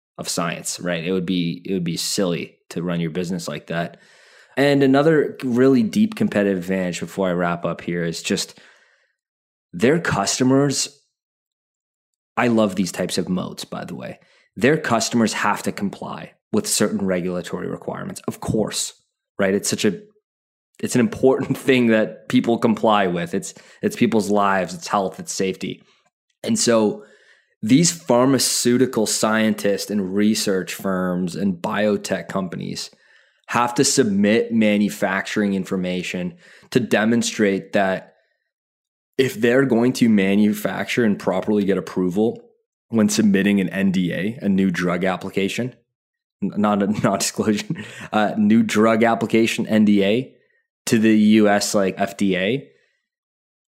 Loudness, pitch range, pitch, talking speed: -20 LUFS, 95-125 Hz, 105 Hz, 135 wpm